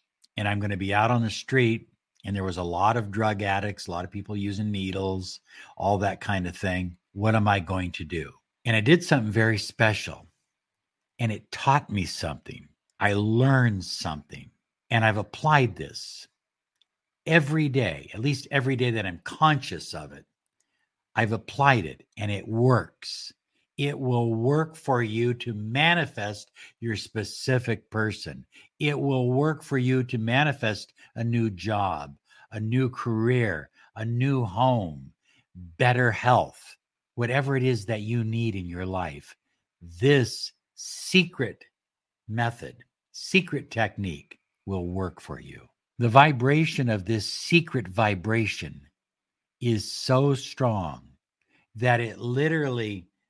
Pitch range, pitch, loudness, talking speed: 95-130 Hz, 110 Hz, -26 LUFS, 145 wpm